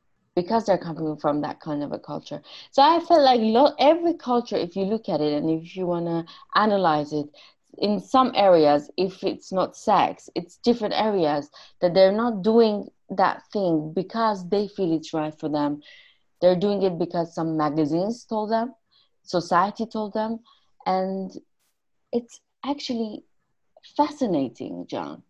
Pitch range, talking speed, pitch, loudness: 165-225 Hz, 160 wpm, 195 Hz, -23 LUFS